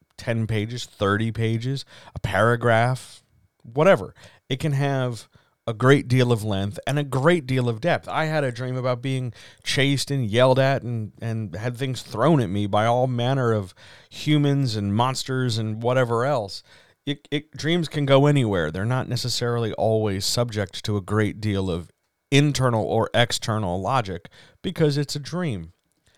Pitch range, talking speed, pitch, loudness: 110-135 Hz, 165 wpm, 120 Hz, -23 LUFS